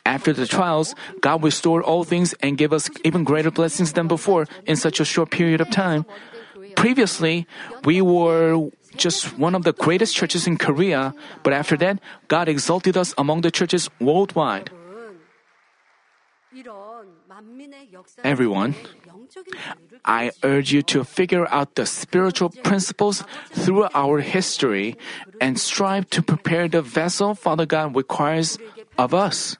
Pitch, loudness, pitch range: 170 Hz, -20 LUFS, 155-190 Hz